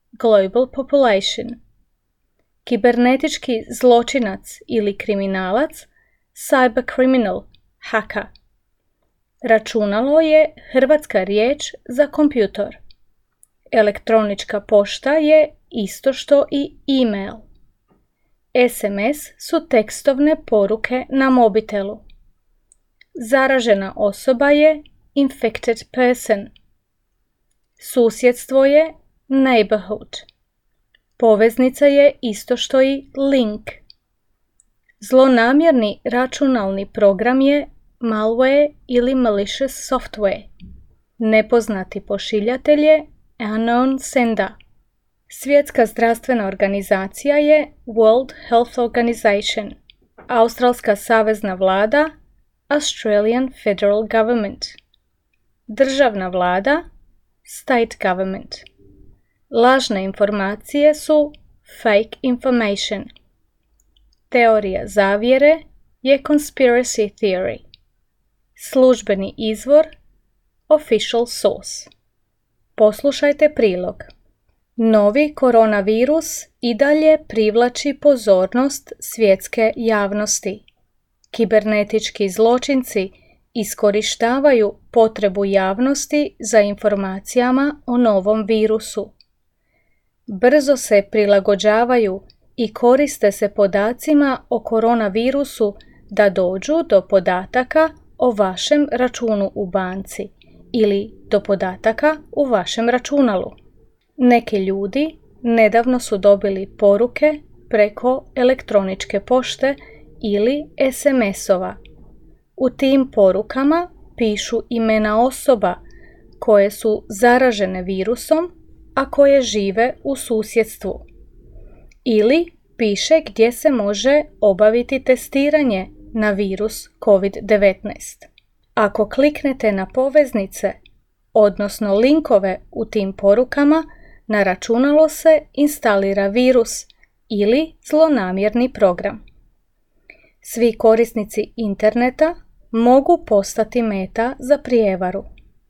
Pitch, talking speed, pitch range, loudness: 230 Hz, 80 wpm, 205-270 Hz, -17 LUFS